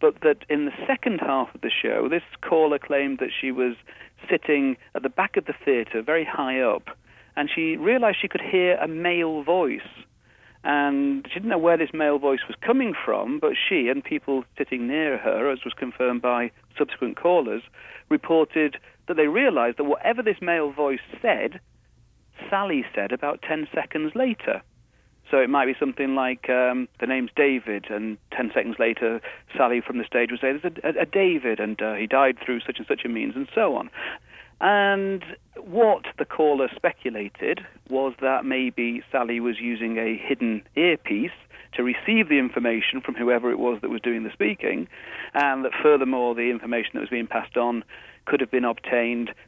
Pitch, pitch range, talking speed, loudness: 135 Hz, 120-170 Hz, 185 wpm, -24 LUFS